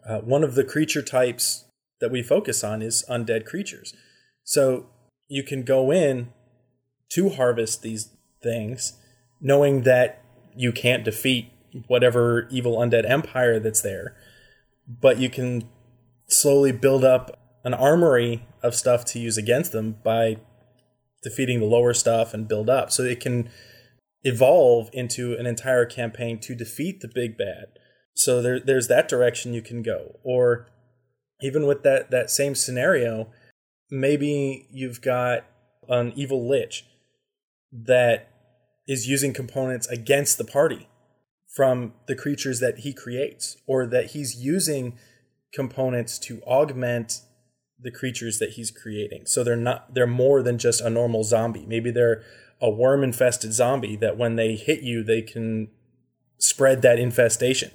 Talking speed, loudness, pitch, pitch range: 145 wpm, -22 LUFS, 125 Hz, 120-135 Hz